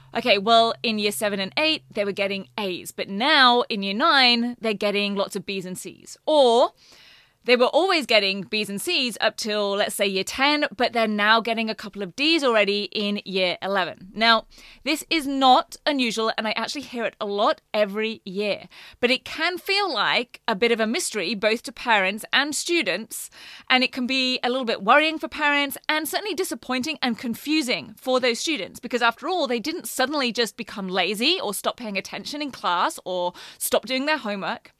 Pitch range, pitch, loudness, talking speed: 205-280 Hz, 235 Hz, -22 LUFS, 200 wpm